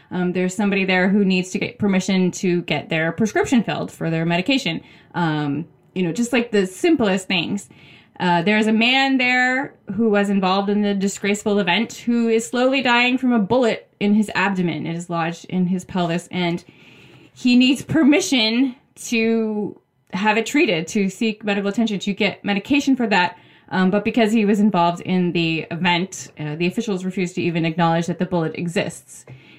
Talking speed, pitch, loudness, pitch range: 185 wpm, 195 Hz, -19 LUFS, 175-225 Hz